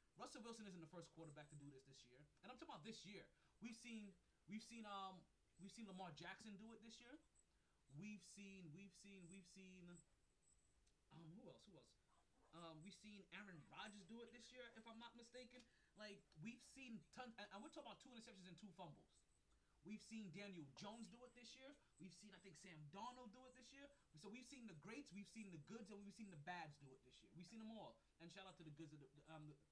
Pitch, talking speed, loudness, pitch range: 200 Hz, 240 wpm, -61 LUFS, 170-225 Hz